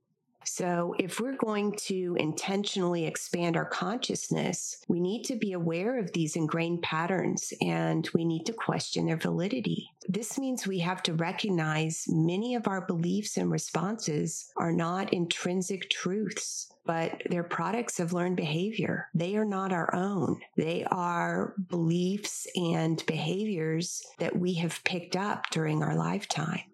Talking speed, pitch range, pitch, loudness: 145 wpm, 165-195 Hz, 180 Hz, -31 LUFS